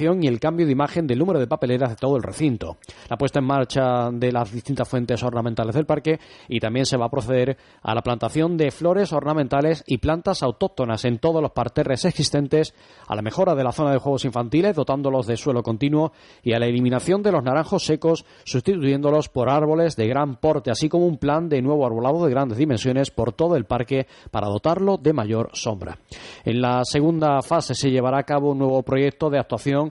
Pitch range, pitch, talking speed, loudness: 125-155 Hz, 140 Hz, 205 wpm, -22 LUFS